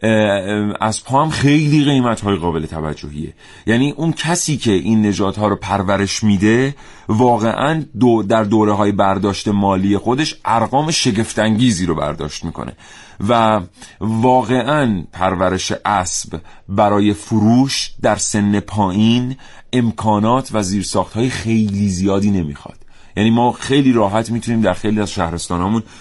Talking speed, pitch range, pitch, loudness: 125 wpm, 100-120 Hz, 110 Hz, -16 LUFS